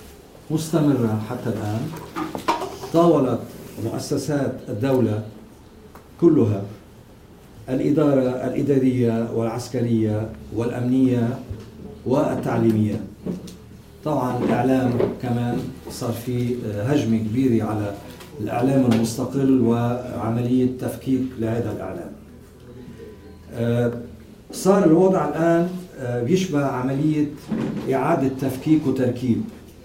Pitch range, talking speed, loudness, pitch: 115-135 Hz, 70 wpm, -22 LUFS, 125 Hz